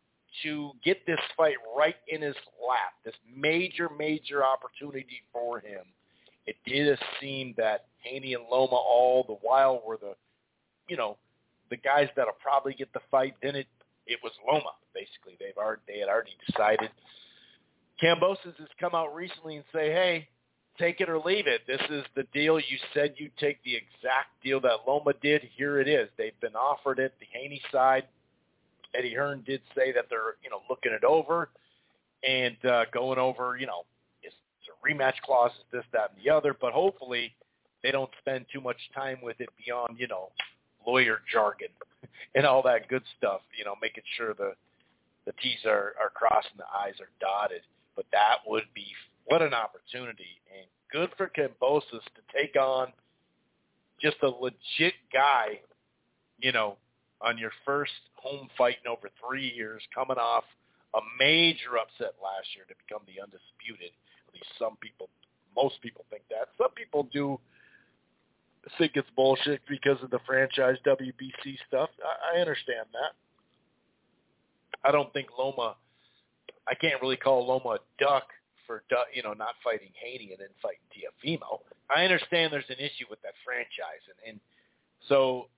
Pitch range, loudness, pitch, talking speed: 125-155 Hz, -29 LUFS, 135 Hz, 170 wpm